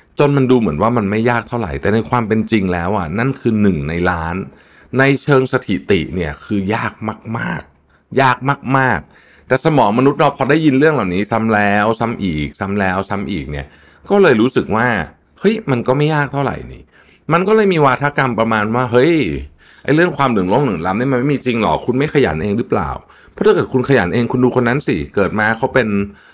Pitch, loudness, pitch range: 115 Hz, -15 LUFS, 100-130 Hz